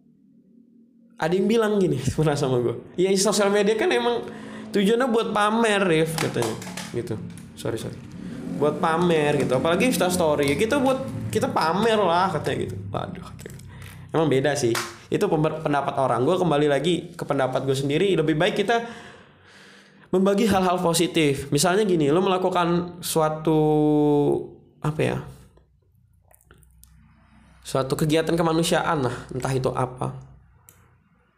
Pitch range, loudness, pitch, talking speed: 135-195 Hz, -22 LUFS, 160 Hz, 125 wpm